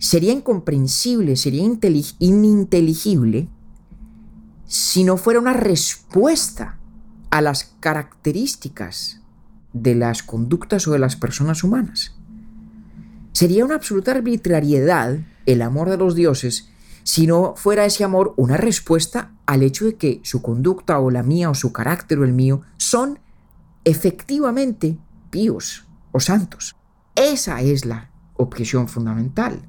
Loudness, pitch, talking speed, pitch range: -18 LUFS, 170 Hz, 125 wpm, 135-210 Hz